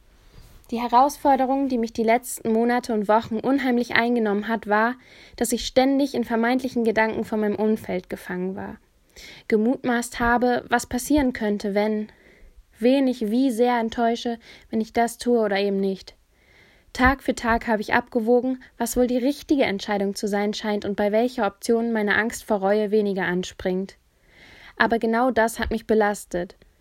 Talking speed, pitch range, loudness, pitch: 160 wpm, 210-245 Hz, -23 LUFS, 230 Hz